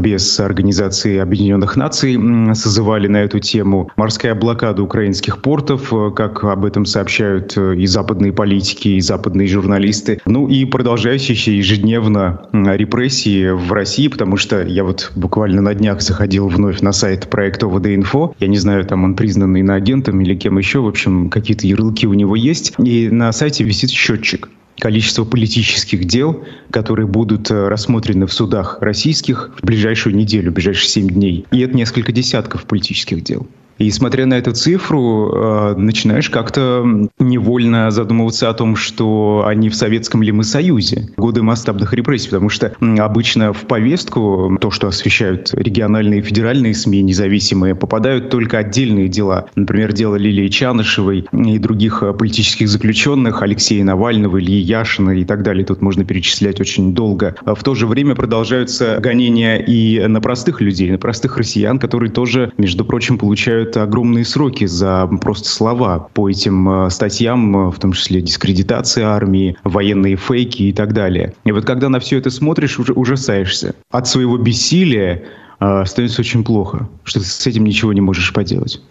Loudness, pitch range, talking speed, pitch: -14 LUFS, 100-120 Hz, 155 wpm, 110 Hz